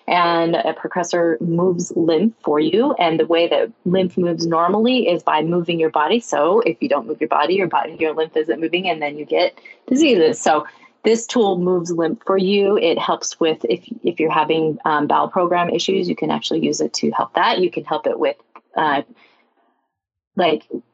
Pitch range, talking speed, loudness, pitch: 155-180 Hz, 200 wpm, -18 LUFS, 170 Hz